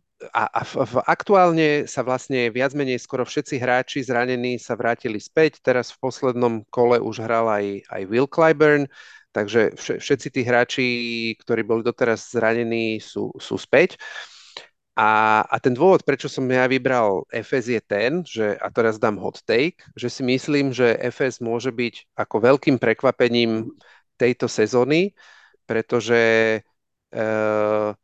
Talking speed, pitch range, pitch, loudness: 150 wpm, 115-135 Hz, 125 Hz, -21 LUFS